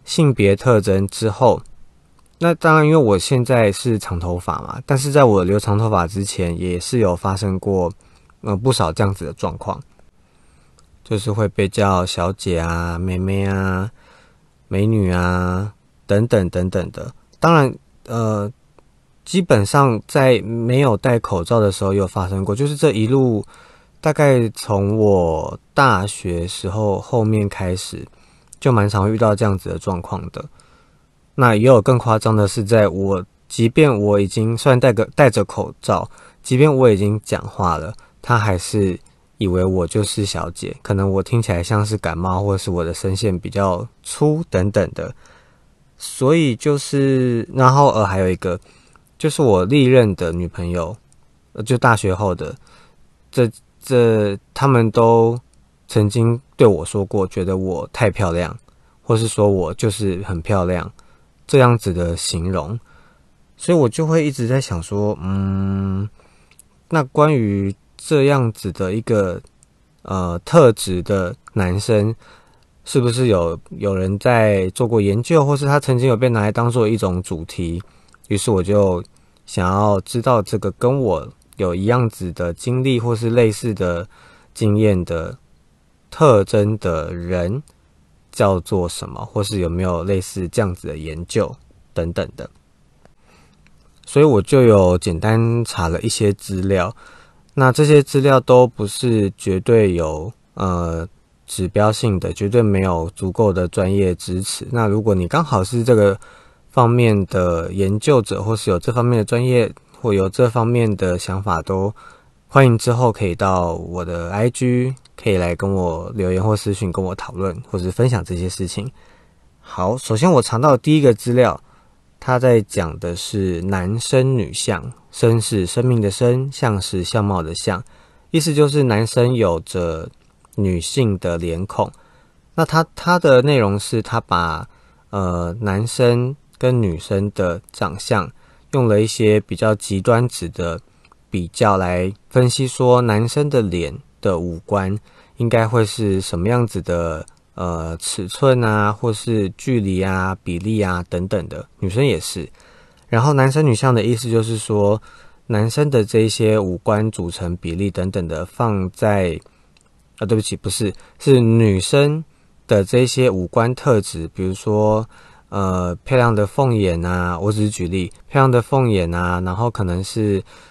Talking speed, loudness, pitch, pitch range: 220 characters per minute, -18 LUFS, 105 Hz, 90-120 Hz